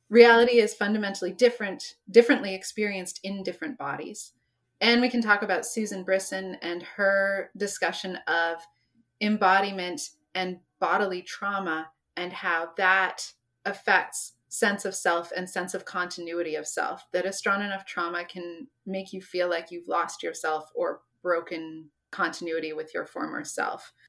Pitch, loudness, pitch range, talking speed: 190 Hz, -27 LUFS, 175-205 Hz, 140 wpm